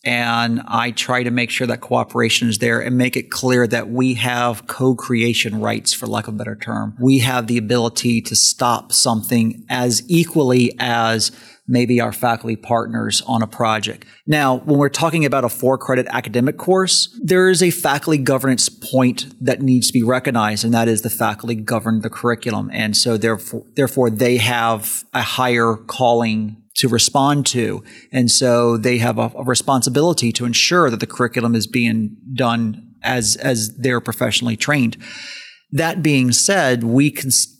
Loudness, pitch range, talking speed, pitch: -17 LUFS, 115-130 Hz, 175 wpm, 120 Hz